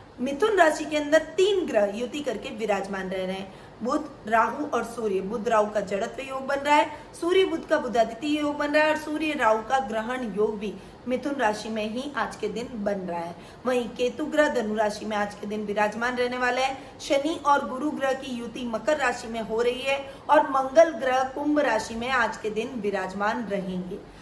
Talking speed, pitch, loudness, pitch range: 210 wpm, 245 Hz, -26 LUFS, 215-290 Hz